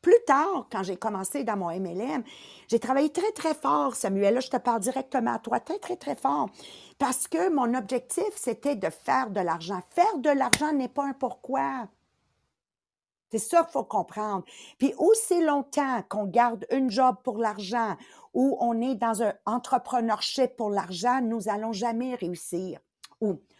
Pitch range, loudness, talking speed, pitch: 215-280 Hz, -27 LUFS, 175 wpm, 250 Hz